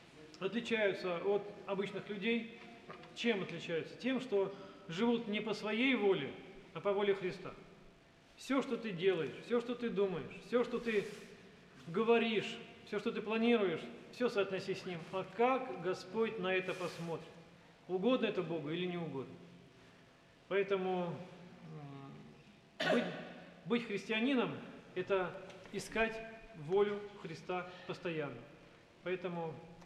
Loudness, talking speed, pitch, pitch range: -37 LUFS, 120 wpm, 195 Hz, 175-220 Hz